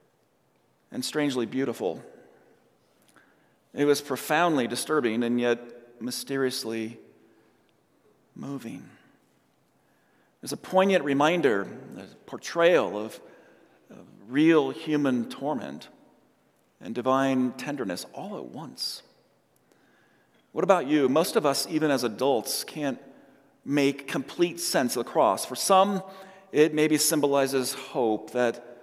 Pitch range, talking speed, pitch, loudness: 125-155 Hz, 105 wpm, 140 Hz, -26 LUFS